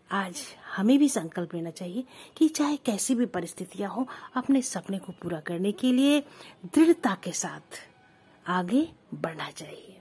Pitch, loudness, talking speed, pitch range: 205 Hz, -28 LUFS, 150 wpm, 180-265 Hz